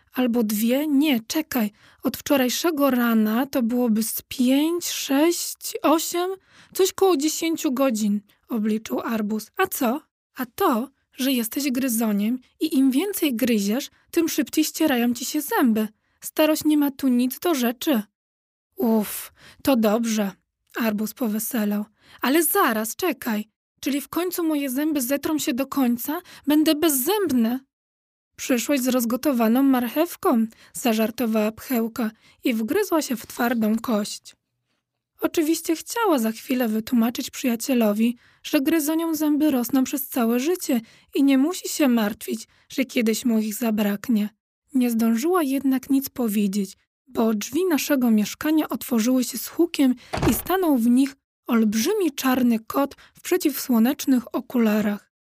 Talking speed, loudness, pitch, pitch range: 130 wpm, -23 LUFS, 260 Hz, 230-310 Hz